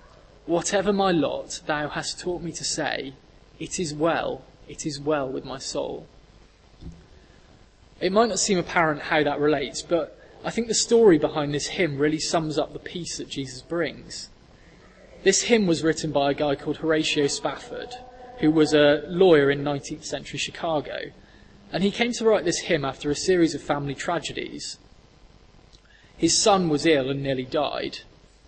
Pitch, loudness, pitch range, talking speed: 155 Hz, -24 LUFS, 145-175 Hz, 170 wpm